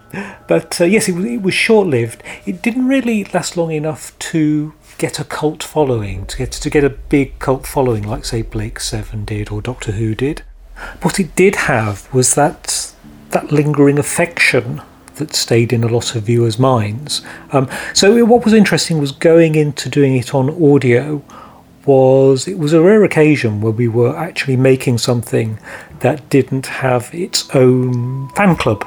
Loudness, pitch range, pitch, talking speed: -14 LUFS, 120-165 Hz, 140 Hz, 170 wpm